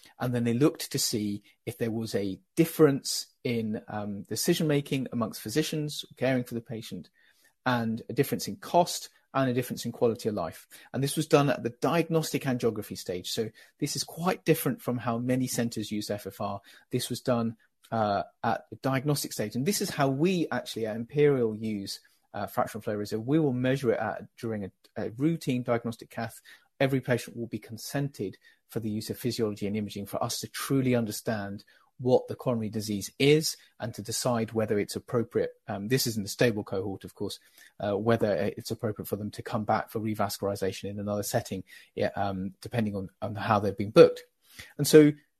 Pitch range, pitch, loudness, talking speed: 105-140 Hz, 115 Hz, -29 LUFS, 195 wpm